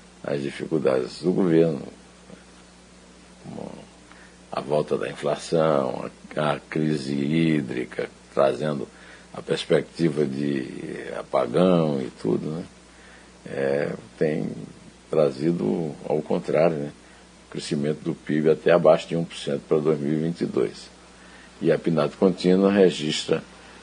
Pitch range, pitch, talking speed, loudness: 70-80 Hz, 75 Hz, 105 wpm, -24 LUFS